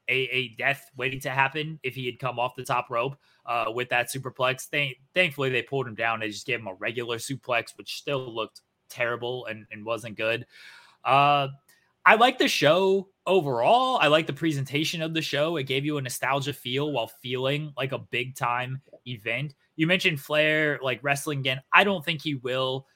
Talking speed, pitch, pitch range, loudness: 200 wpm, 135 Hz, 125-150 Hz, -26 LUFS